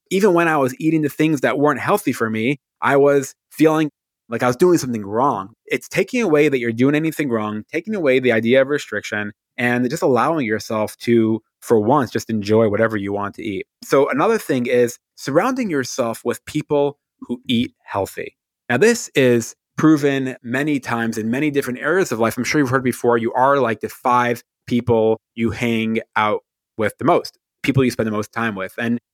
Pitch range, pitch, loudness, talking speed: 115-150 Hz, 125 Hz, -19 LUFS, 200 wpm